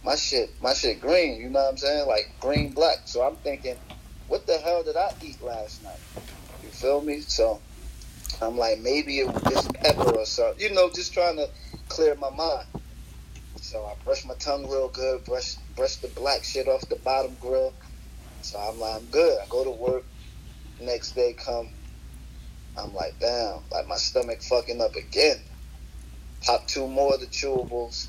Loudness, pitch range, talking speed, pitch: -26 LUFS, 110-150 Hz, 190 wpm, 130 Hz